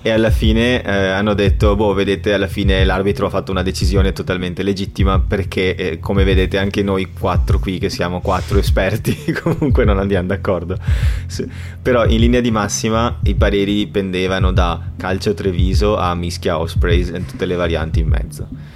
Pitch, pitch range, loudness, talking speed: 95 Hz, 90-100 Hz, -17 LUFS, 175 wpm